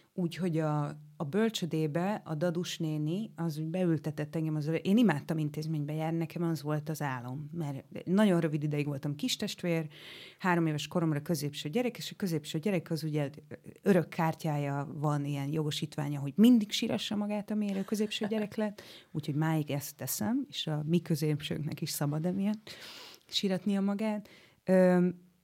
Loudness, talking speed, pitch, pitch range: -32 LUFS, 155 wpm, 165 Hz, 150-195 Hz